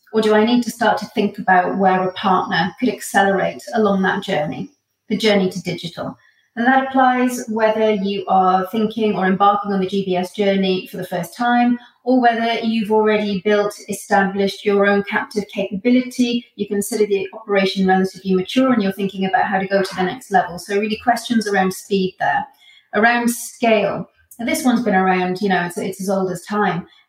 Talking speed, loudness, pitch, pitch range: 190 wpm, -18 LUFS, 205 Hz, 190-225 Hz